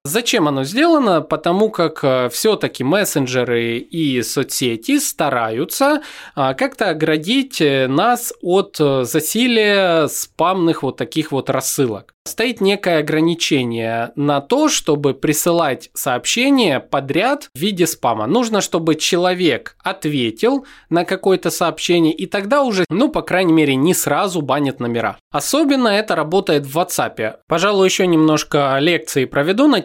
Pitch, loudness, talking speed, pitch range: 170 Hz, -17 LUFS, 125 wpm, 145-205 Hz